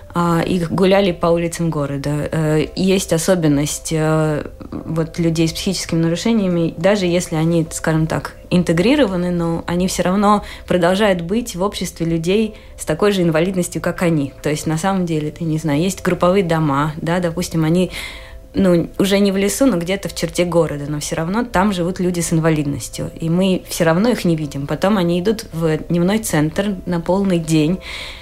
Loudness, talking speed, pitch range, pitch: -18 LUFS, 170 wpm, 160-185 Hz, 170 Hz